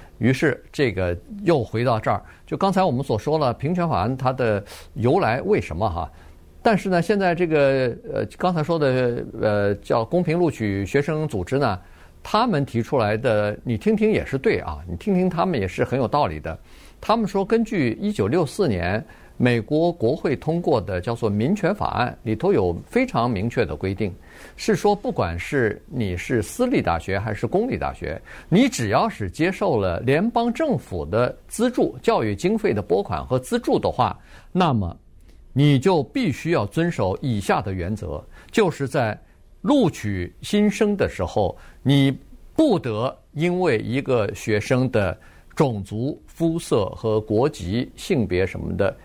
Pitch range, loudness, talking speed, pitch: 105-175 Hz, -22 LUFS, 245 characters per minute, 130 Hz